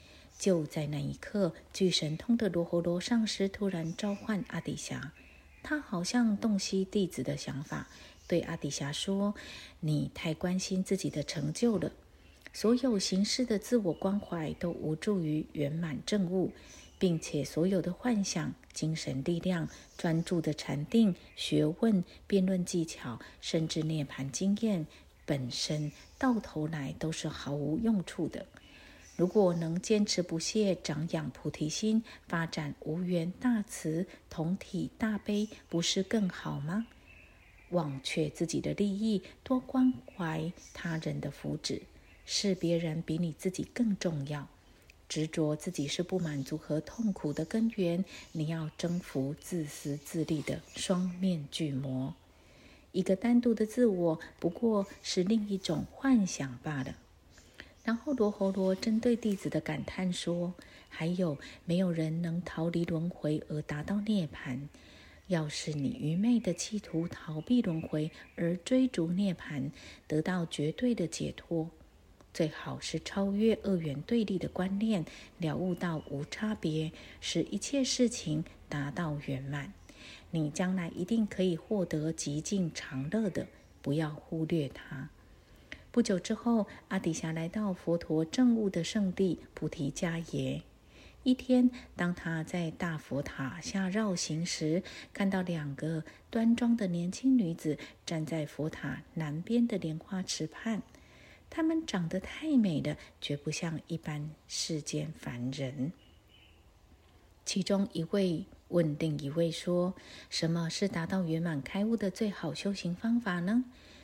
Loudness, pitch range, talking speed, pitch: -33 LUFS, 155-200 Hz, 205 characters per minute, 170 Hz